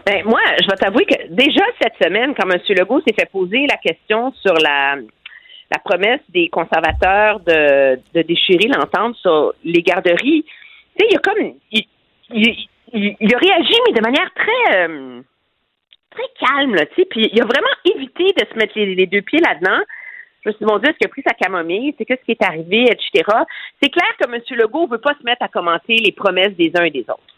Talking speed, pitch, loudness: 215 wpm, 235 Hz, -15 LUFS